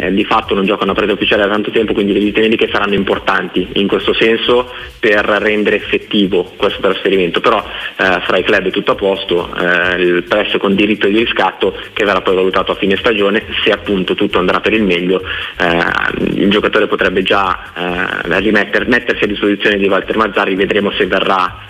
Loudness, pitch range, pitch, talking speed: -13 LUFS, 90-105 Hz, 100 Hz, 195 wpm